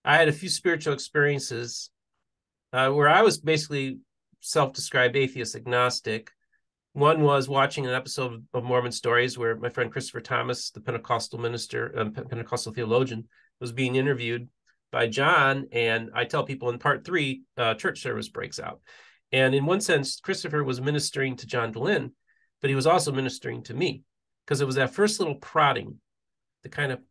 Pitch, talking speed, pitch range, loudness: 130 Hz, 175 wpm, 120-145 Hz, -26 LUFS